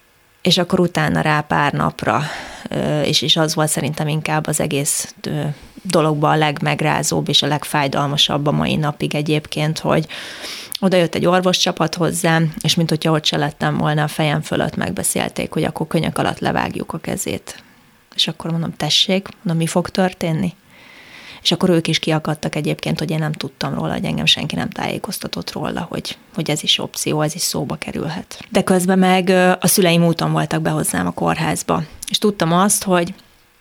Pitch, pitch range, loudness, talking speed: 165 Hz, 150-185 Hz, -18 LUFS, 170 wpm